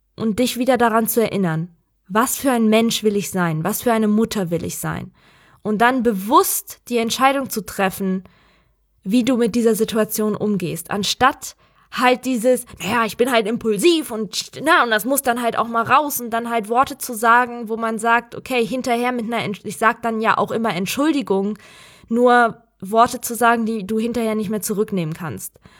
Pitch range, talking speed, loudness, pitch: 210-240 Hz, 195 wpm, -19 LUFS, 230 Hz